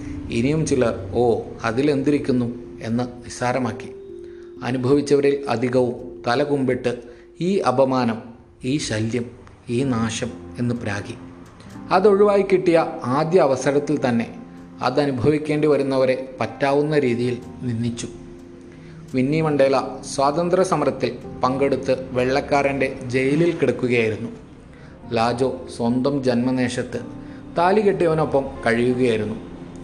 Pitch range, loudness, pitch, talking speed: 120-145 Hz, -21 LUFS, 130 Hz, 80 wpm